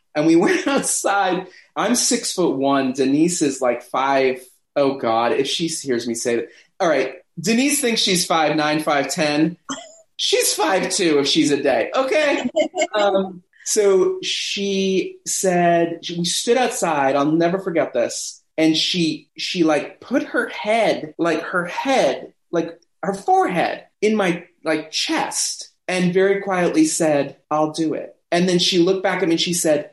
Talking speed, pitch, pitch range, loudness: 165 wpm, 175 Hz, 150-210 Hz, -19 LUFS